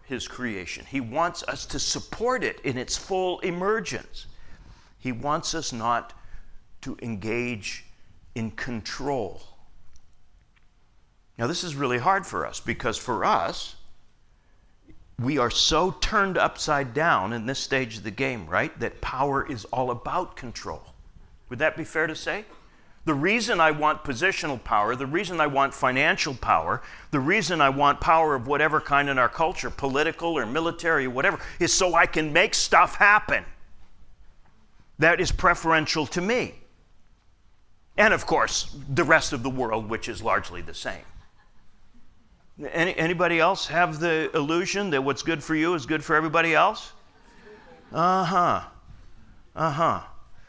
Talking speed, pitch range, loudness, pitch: 150 wpm, 110-165 Hz, -24 LUFS, 140 Hz